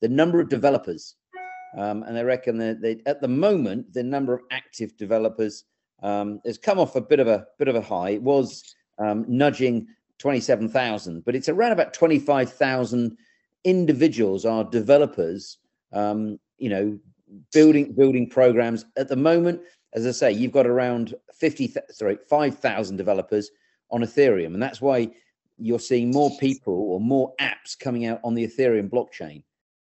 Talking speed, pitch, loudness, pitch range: 170 wpm, 125 Hz, -23 LUFS, 110-145 Hz